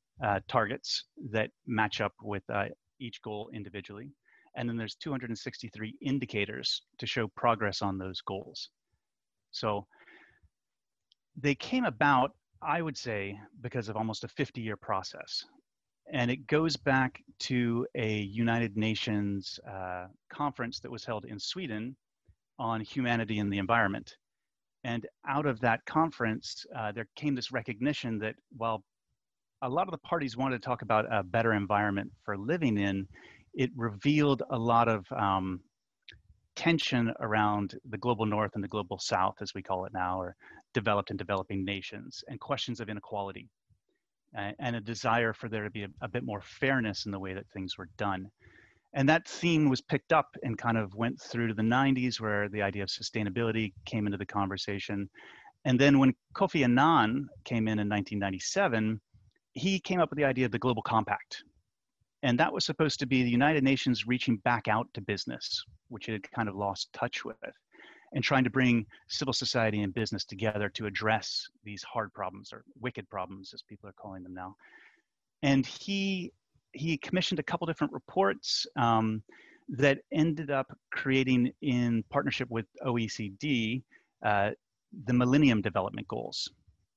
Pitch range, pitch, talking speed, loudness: 105-130 Hz, 115 Hz, 165 wpm, -31 LUFS